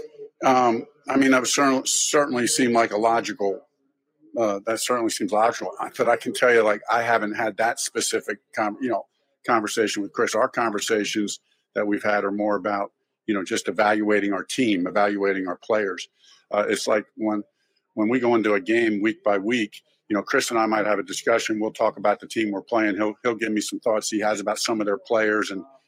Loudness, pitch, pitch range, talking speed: -23 LUFS, 110 Hz, 105-120 Hz, 215 wpm